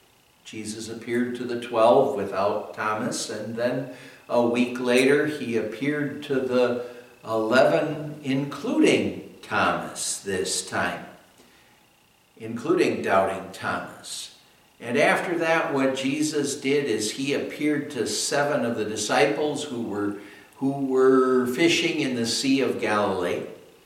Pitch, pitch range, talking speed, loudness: 130 Hz, 120-150 Hz, 120 wpm, -24 LUFS